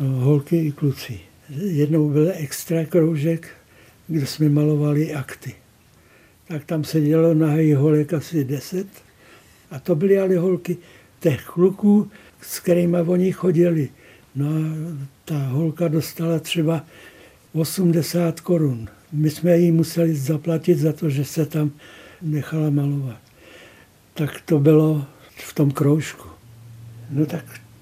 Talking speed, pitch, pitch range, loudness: 125 wpm, 155 Hz, 145-165 Hz, -21 LUFS